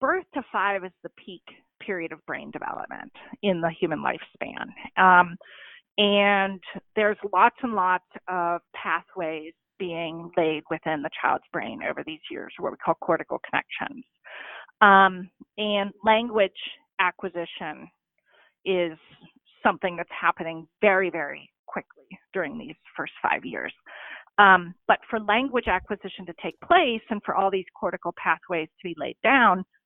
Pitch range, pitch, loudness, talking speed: 170-215 Hz, 190 Hz, -24 LUFS, 140 wpm